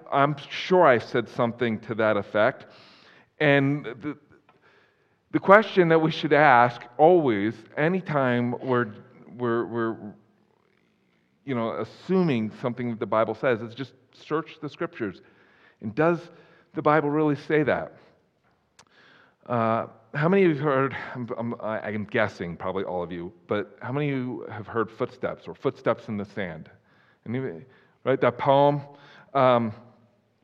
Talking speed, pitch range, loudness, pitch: 145 wpm, 115-150 Hz, -25 LUFS, 125 Hz